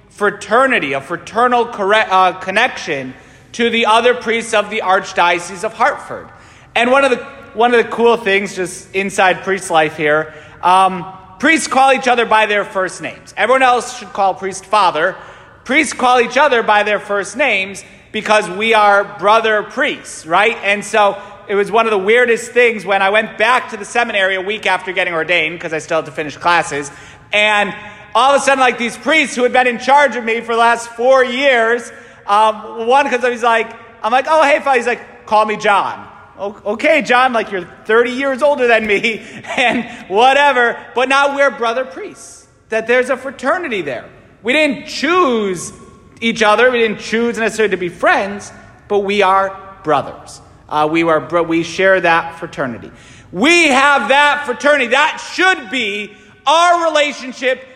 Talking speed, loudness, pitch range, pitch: 180 wpm, -14 LUFS, 195-250 Hz, 220 Hz